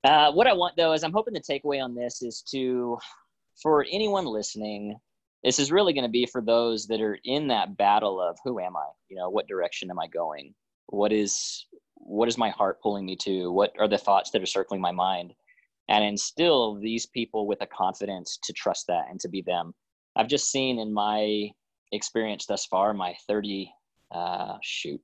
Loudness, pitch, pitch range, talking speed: -27 LUFS, 110 Hz, 105-130 Hz, 205 wpm